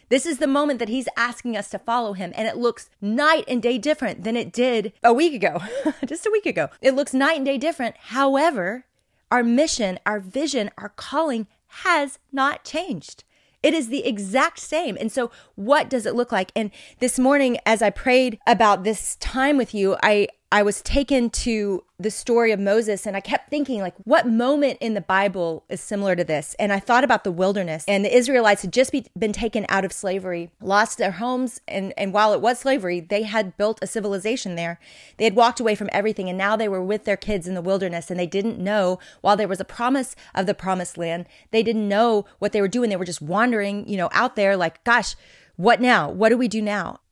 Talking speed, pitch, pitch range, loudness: 225 wpm, 220 Hz, 200-255 Hz, -22 LUFS